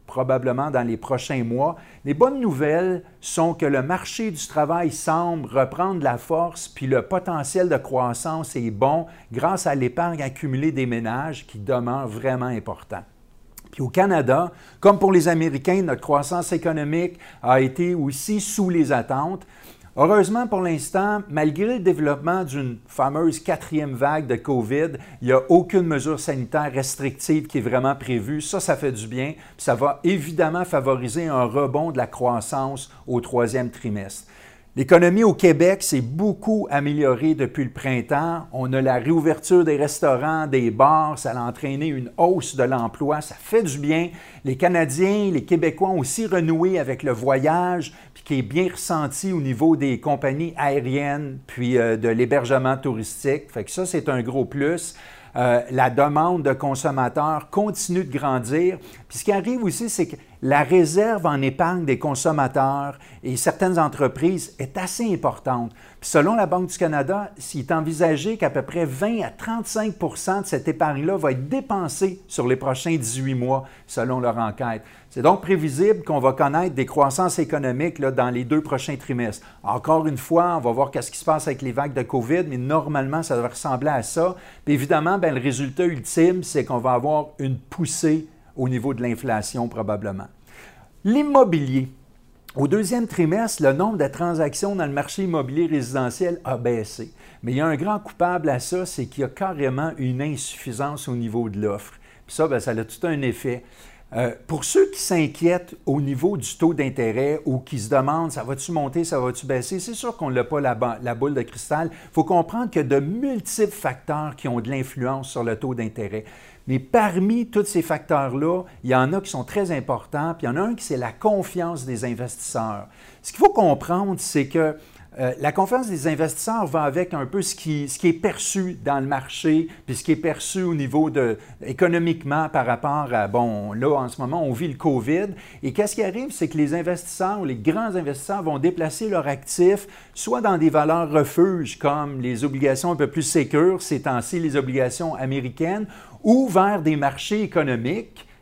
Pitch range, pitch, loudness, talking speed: 130-175 Hz, 150 Hz, -22 LUFS, 185 wpm